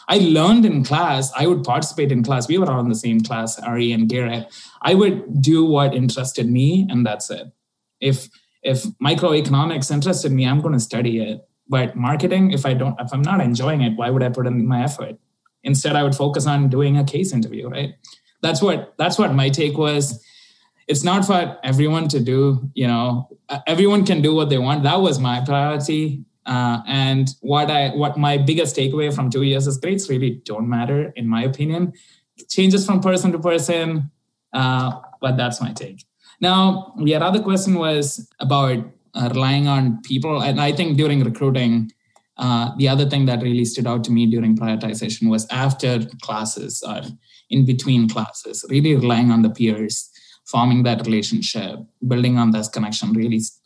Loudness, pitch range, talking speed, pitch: -19 LUFS, 120-150 Hz, 190 wpm, 135 Hz